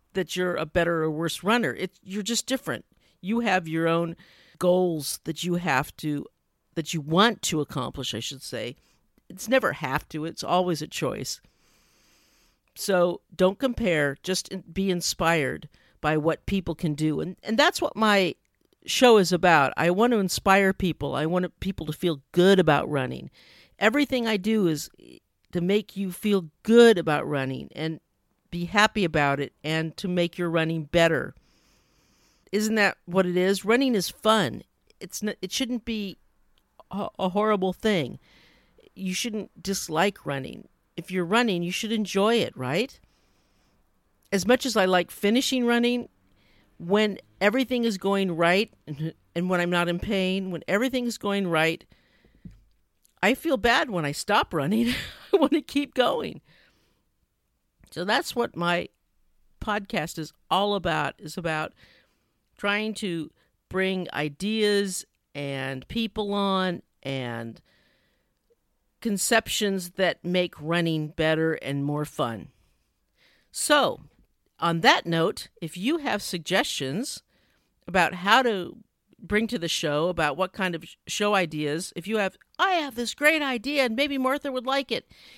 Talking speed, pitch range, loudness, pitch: 150 wpm, 160-215 Hz, -25 LUFS, 185 Hz